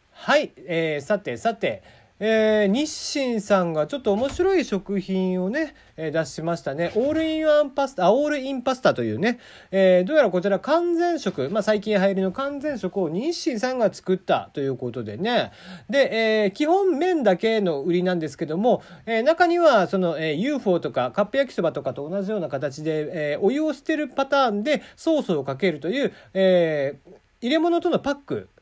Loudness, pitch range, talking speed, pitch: -23 LUFS, 175-280 Hz, 340 characters per minute, 205 Hz